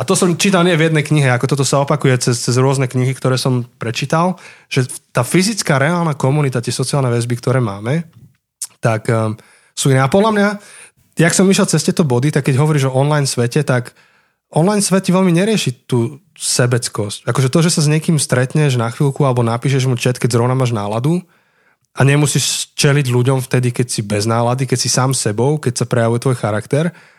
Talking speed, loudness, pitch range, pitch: 200 wpm, -15 LUFS, 125-155 Hz, 135 Hz